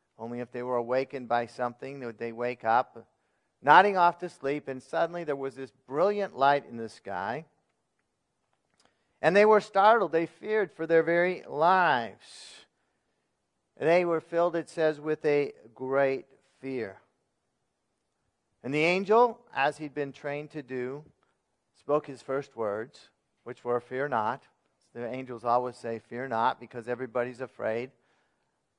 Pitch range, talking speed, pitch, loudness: 120-165 Hz, 150 wpm, 135 Hz, -28 LUFS